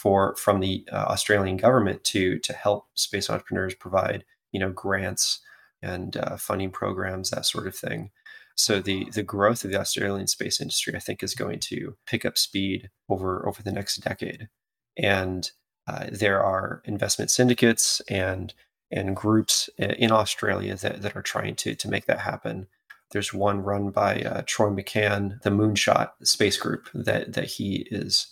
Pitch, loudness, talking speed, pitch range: 100 Hz, -25 LUFS, 170 wpm, 95-105 Hz